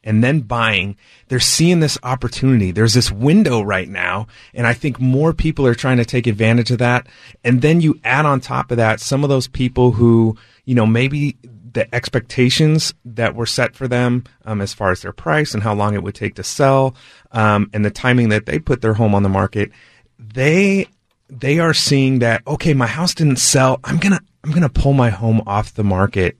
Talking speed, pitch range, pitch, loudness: 210 wpm, 110-140 Hz, 125 Hz, -16 LUFS